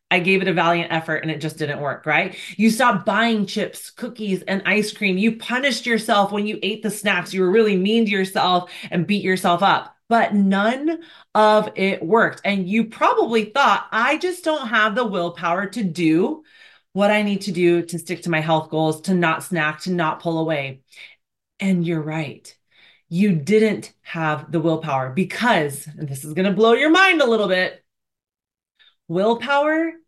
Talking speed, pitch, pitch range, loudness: 190 wpm, 195 Hz, 170-225 Hz, -19 LUFS